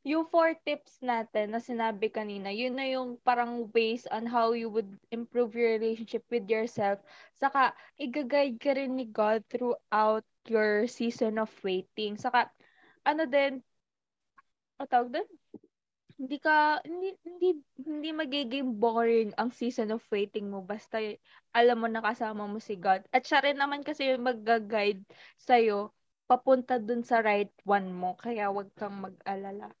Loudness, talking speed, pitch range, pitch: -30 LUFS, 150 wpm, 215-265 Hz, 235 Hz